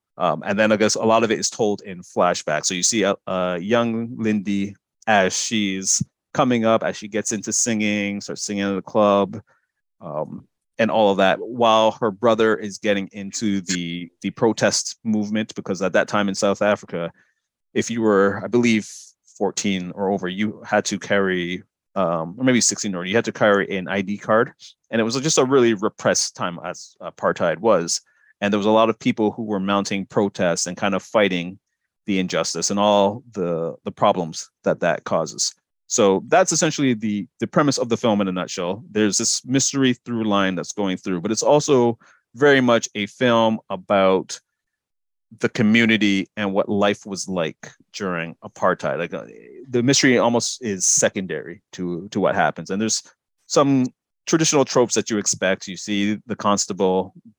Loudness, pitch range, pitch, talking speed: -20 LUFS, 95-115 Hz, 105 Hz, 185 wpm